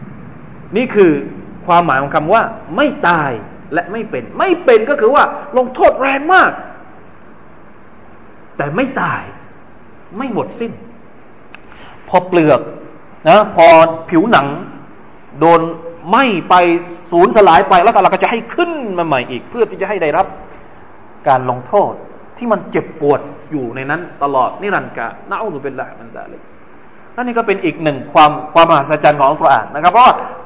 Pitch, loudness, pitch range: 175 Hz, -13 LUFS, 160-235 Hz